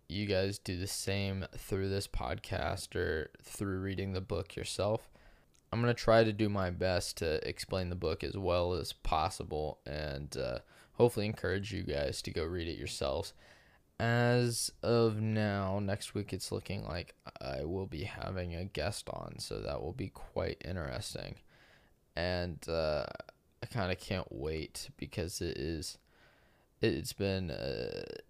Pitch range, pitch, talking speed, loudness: 85-105 Hz, 95 Hz, 155 wpm, -36 LUFS